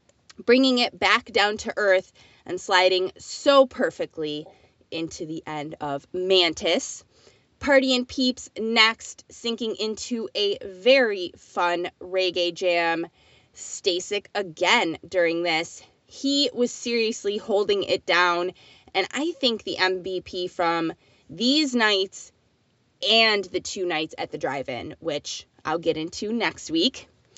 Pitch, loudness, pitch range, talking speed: 190 Hz, -23 LUFS, 175-235 Hz, 125 wpm